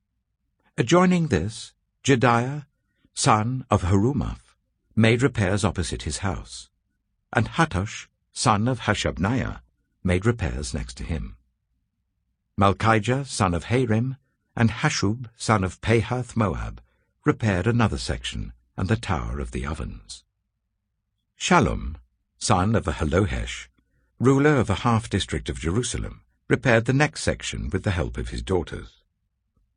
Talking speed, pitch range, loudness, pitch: 120 wpm, 95-120 Hz, -24 LUFS, 105 Hz